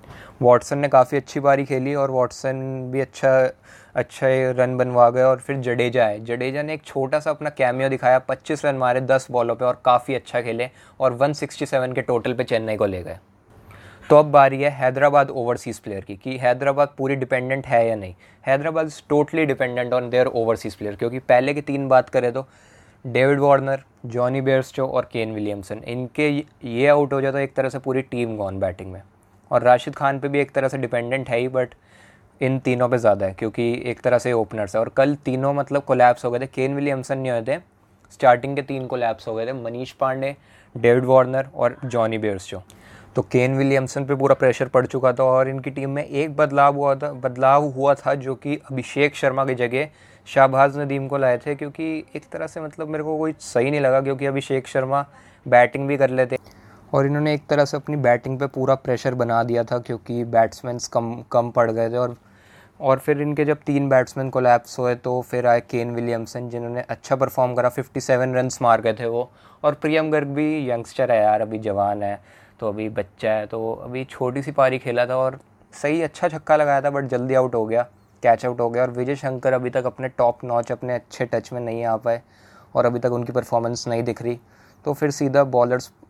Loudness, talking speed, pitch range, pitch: -21 LUFS, 210 wpm, 120-140 Hz, 130 Hz